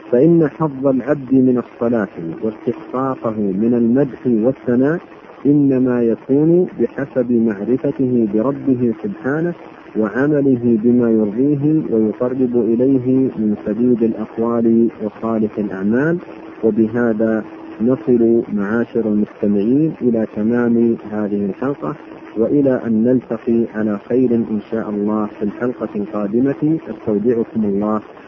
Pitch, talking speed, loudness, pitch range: 115 Hz, 100 wpm, -17 LUFS, 110-130 Hz